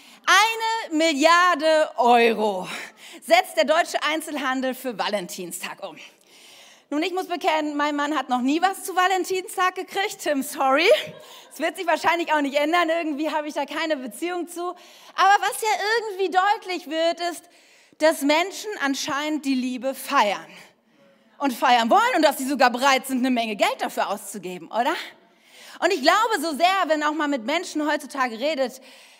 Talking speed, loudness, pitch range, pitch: 160 wpm, -22 LUFS, 270-350 Hz, 310 Hz